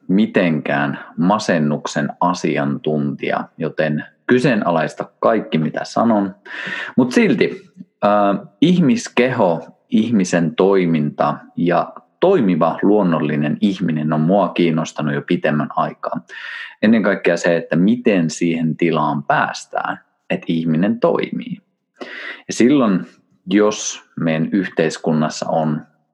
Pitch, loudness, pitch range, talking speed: 80 Hz, -18 LUFS, 75-95 Hz, 95 wpm